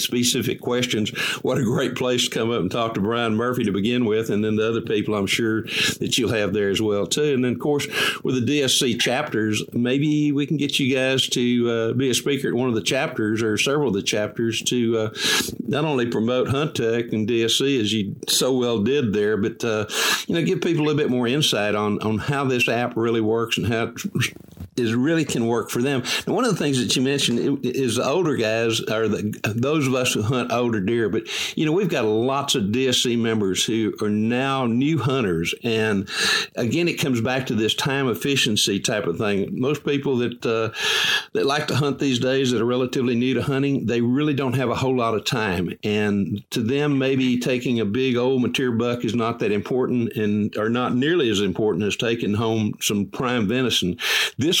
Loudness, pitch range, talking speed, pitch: -21 LUFS, 110-130 Hz, 220 wpm, 120 Hz